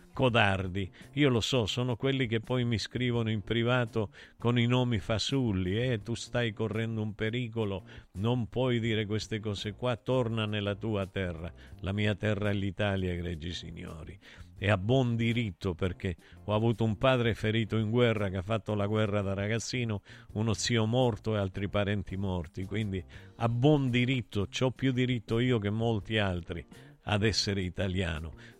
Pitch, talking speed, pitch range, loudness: 110 Hz, 170 wpm, 100-120 Hz, -31 LUFS